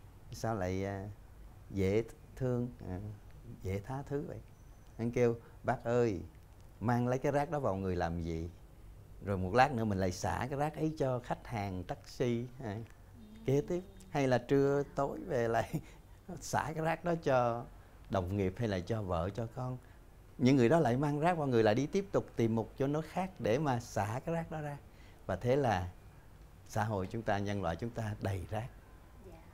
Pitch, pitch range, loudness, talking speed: 115 Hz, 95-130 Hz, -35 LUFS, 190 wpm